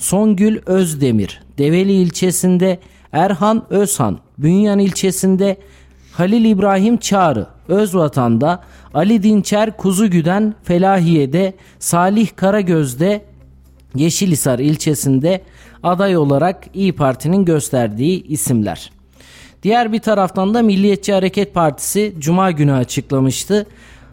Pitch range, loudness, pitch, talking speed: 140-200 Hz, -15 LUFS, 180 Hz, 90 wpm